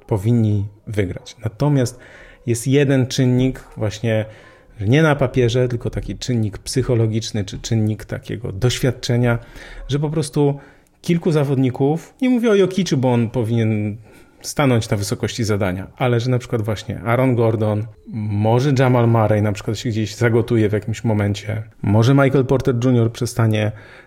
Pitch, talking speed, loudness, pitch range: 120 Hz, 140 wpm, -19 LUFS, 110-130 Hz